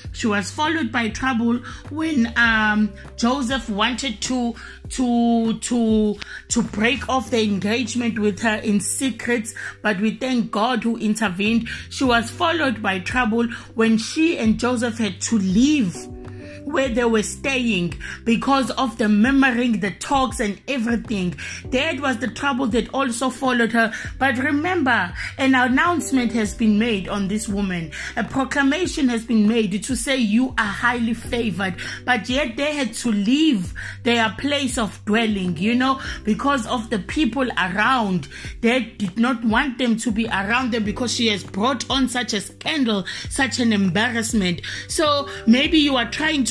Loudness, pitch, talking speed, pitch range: -20 LUFS, 235 Hz, 160 wpm, 215-260 Hz